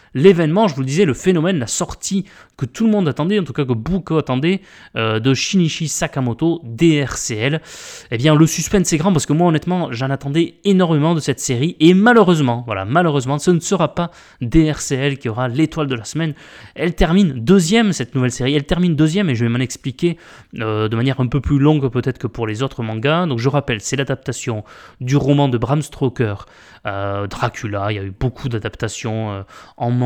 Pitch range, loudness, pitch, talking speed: 120-170 Hz, -17 LUFS, 145 Hz, 205 wpm